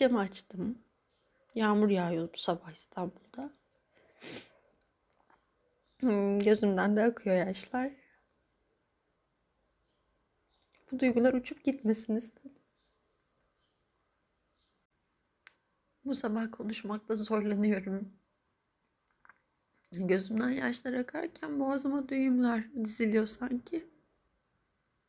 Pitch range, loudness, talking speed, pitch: 205-265 Hz, -32 LUFS, 60 wpm, 230 Hz